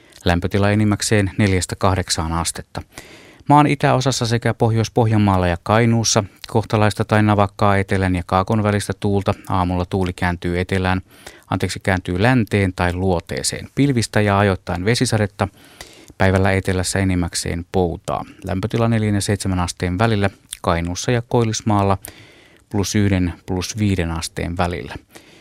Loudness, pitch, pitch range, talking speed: -19 LUFS, 100 Hz, 90-110 Hz, 115 wpm